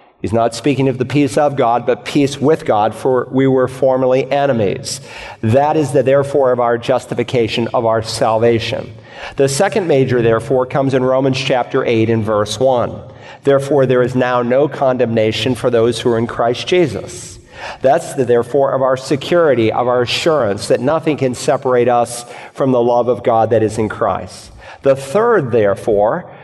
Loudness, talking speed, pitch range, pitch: -15 LUFS, 175 wpm, 115-135 Hz, 125 Hz